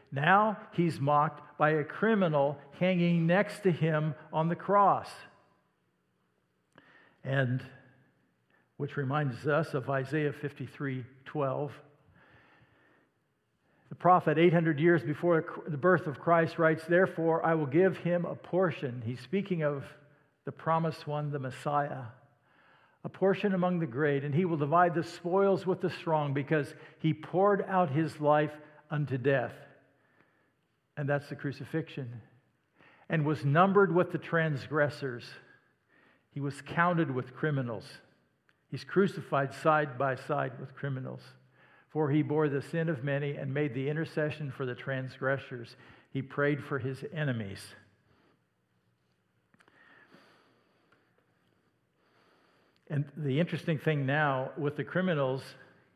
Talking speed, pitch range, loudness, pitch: 125 wpm, 135-165 Hz, -30 LUFS, 150 Hz